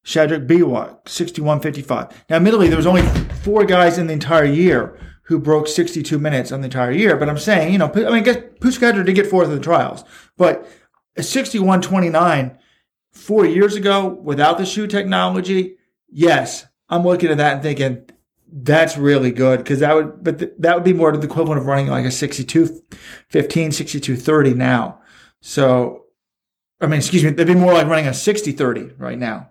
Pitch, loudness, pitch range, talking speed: 160 Hz, -16 LUFS, 145-185 Hz, 185 wpm